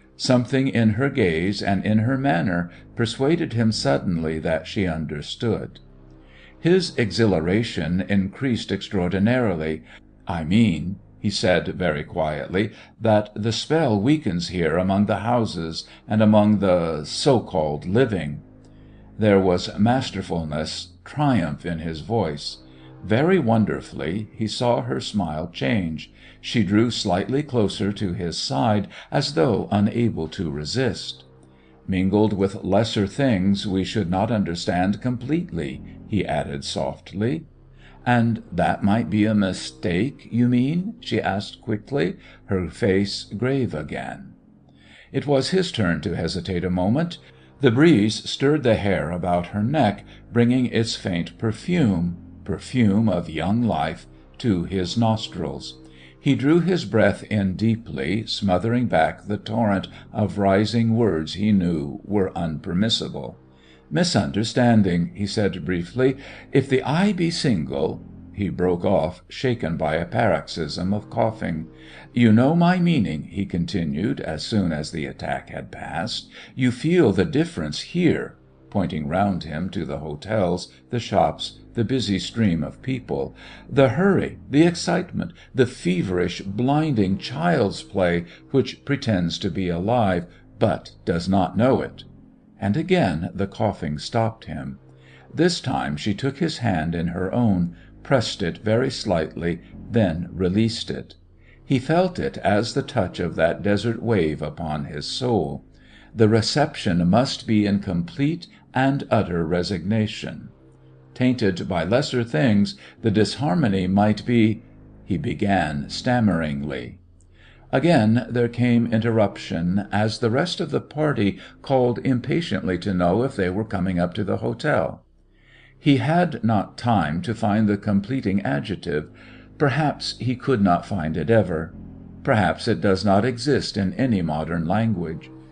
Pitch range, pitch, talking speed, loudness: 90-120 Hz, 105 Hz, 135 wpm, -22 LUFS